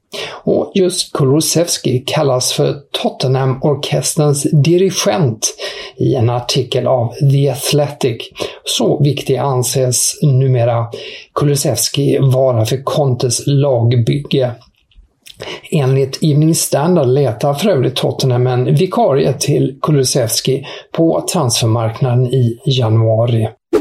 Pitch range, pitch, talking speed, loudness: 125-145 Hz, 135 Hz, 95 wpm, -14 LUFS